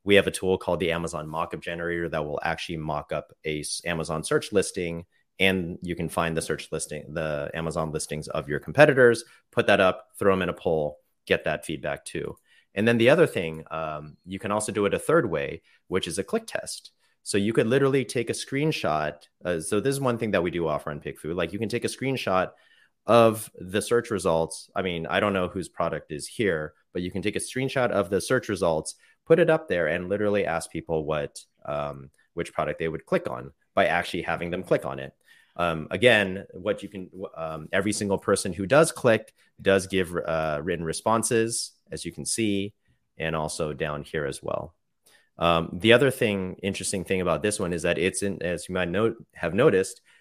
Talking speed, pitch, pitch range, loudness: 215 wpm, 95 Hz, 80-105 Hz, -26 LUFS